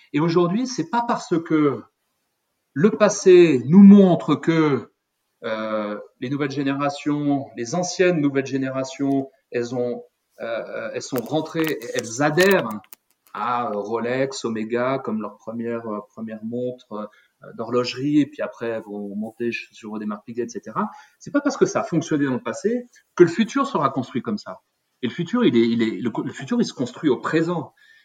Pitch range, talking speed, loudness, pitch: 115-175 Hz, 170 wpm, -21 LUFS, 140 Hz